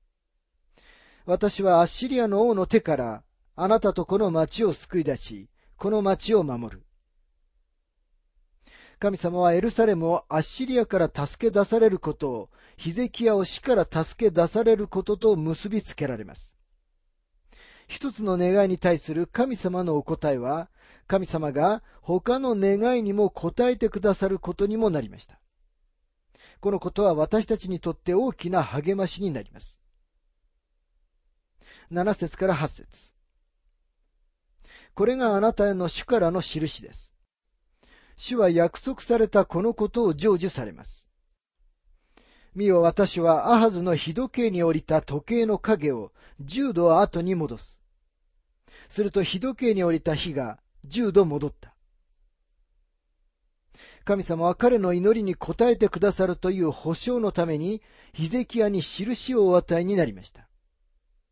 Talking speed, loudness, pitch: 265 characters per minute, -24 LUFS, 175 Hz